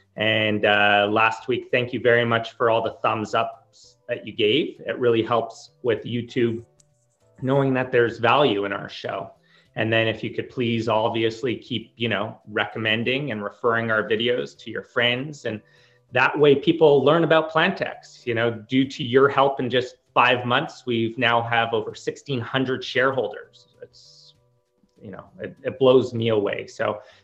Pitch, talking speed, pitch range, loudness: 120 Hz, 170 wpm, 115-135 Hz, -22 LUFS